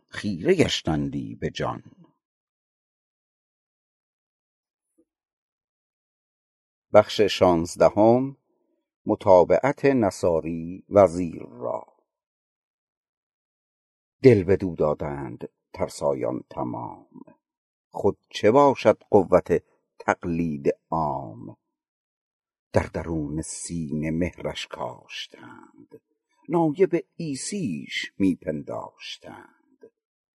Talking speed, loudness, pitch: 55 wpm, -23 LUFS, 90 Hz